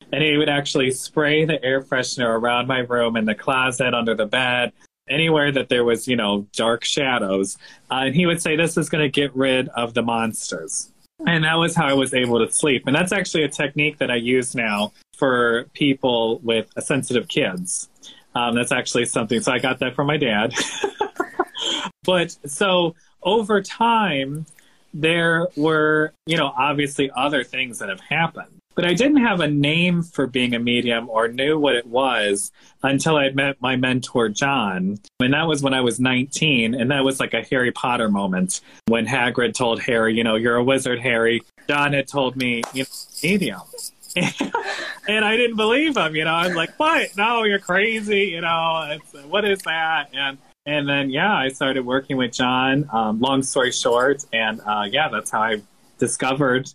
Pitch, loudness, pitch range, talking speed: 140 Hz, -20 LUFS, 120-160 Hz, 190 wpm